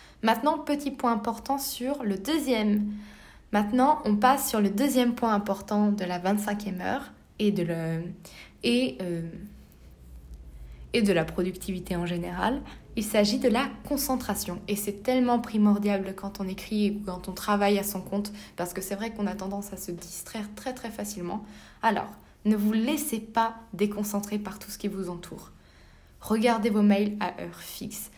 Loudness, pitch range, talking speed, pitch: -28 LUFS, 185-225 Hz, 170 wpm, 205 Hz